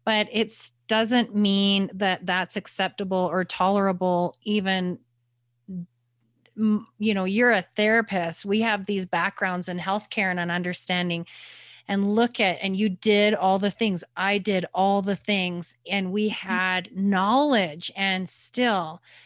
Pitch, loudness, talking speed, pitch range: 195 Hz, -24 LUFS, 135 wpm, 180-210 Hz